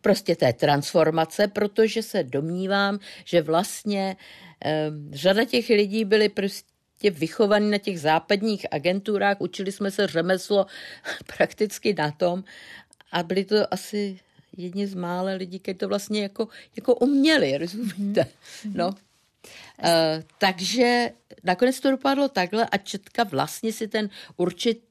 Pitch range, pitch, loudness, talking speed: 180-215 Hz, 200 Hz, -24 LUFS, 130 wpm